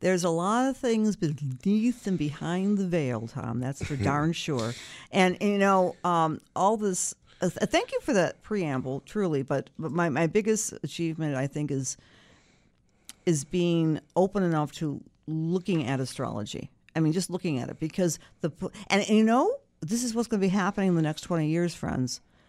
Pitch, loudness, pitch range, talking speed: 170 Hz, -28 LUFS, 145-195 Hz, 190 wpm